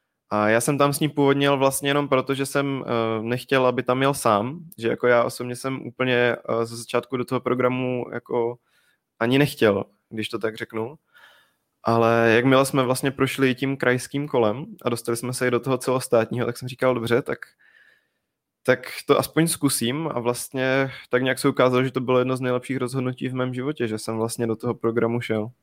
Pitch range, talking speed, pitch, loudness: 115-135 Hz, 195 wpm, 125 Hz, -23 LUFS